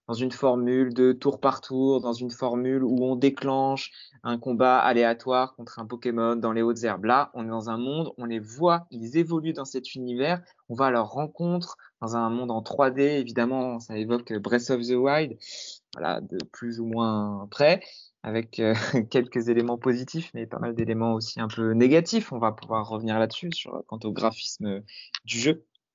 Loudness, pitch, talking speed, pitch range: -26 LUFS, 120 Hz, 195 wpm, 115-135 Hz